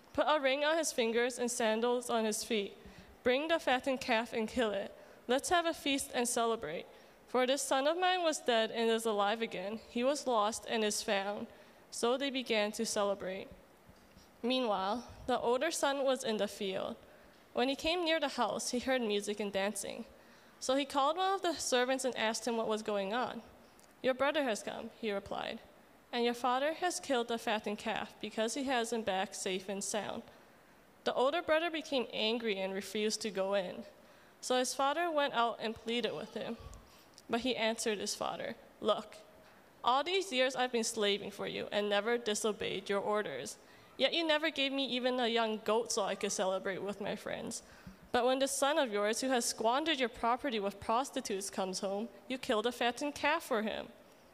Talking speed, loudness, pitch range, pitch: 195 wpm, -34 LUFS, 210-265 Hz, 235 Hz